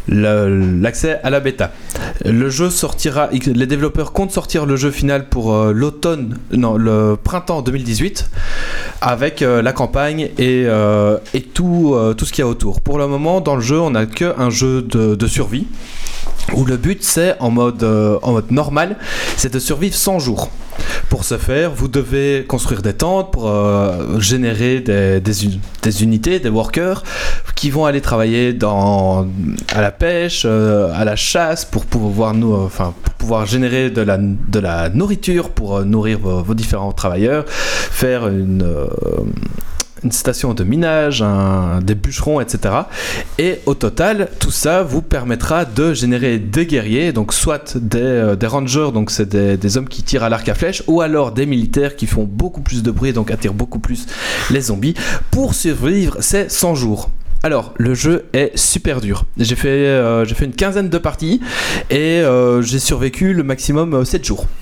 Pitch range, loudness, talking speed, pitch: 105-145 Hz, -16 LUFS, 185 wpm, 125 Hz